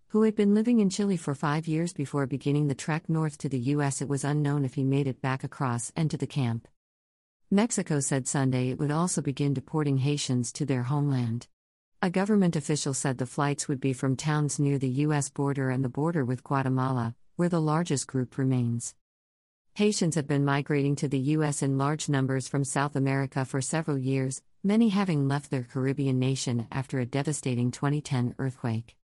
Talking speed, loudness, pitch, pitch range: 190 wpm, -28 LUFS, 140 Hz, 130-150 Hz